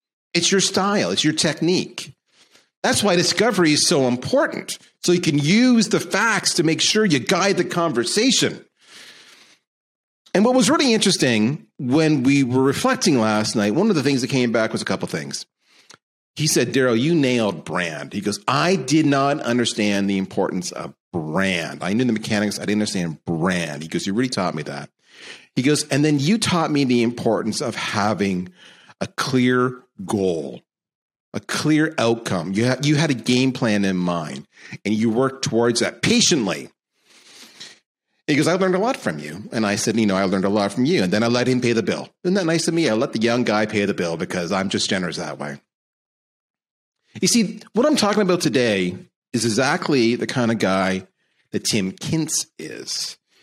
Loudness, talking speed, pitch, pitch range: -20 LUFS, 195 wpm, 130 Hz, 105-170 Hz